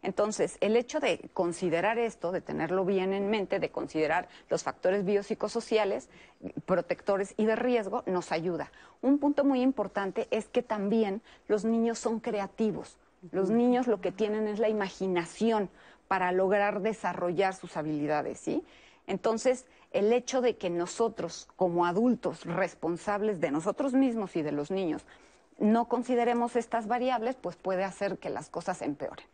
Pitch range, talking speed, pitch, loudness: 185-230 Hz, 155 wpm, 205 Hz, -30 LUFS